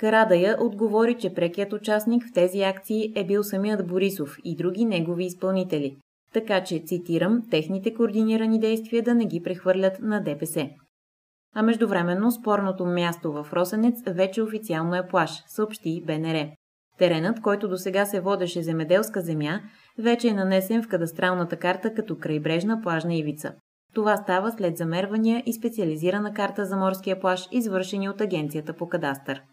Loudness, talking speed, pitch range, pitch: -25 LUFS, 150 wpm, 170-215 Hz, 190 Hz